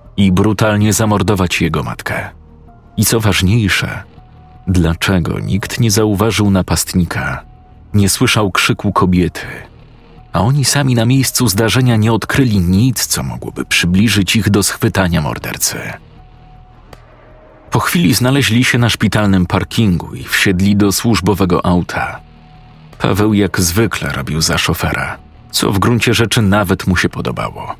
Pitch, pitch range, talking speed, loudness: 100 Hz, 90-115 Hz, 125 wpm, -13 LUFS